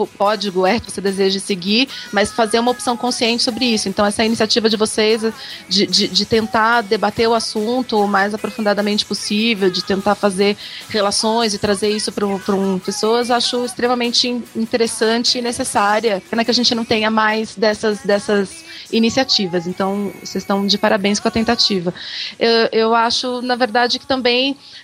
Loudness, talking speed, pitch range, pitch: -17 LUFS, 170 wpm, 205-235 Hz, 220 Hz